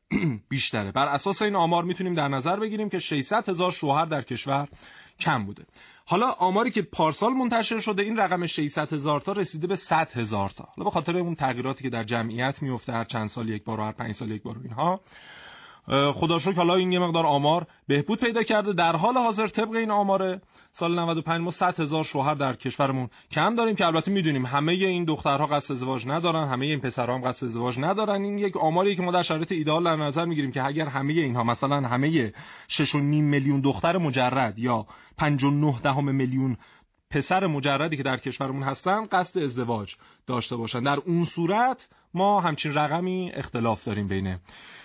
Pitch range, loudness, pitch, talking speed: 130-180 Hz, -25 LUFS, 155 Hz, 185 wpm